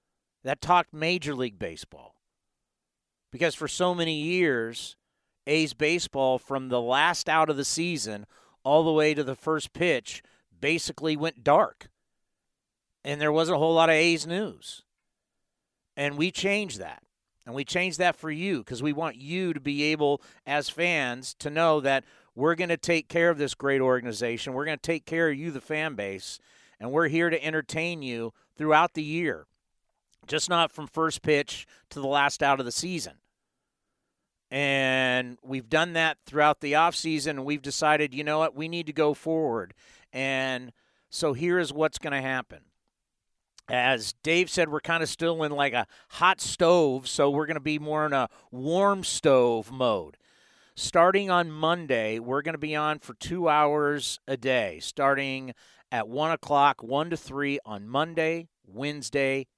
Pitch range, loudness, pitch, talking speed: 135-165 Hz, -26 LUFS, 150 Hz, 175 wpm